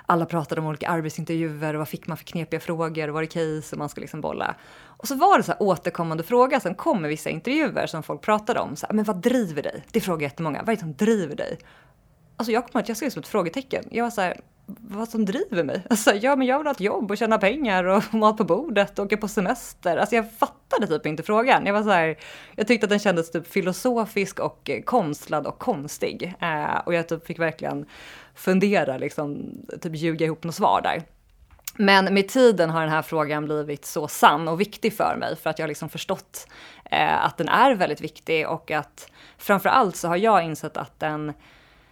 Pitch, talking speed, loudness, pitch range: 185 Hz, 225 wpm, -23 LUFS, 160-225 Hz